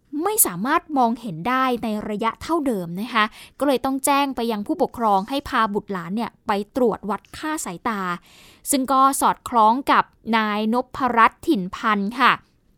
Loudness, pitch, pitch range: -21 LUFS, 230 Hz, 210-270 Hz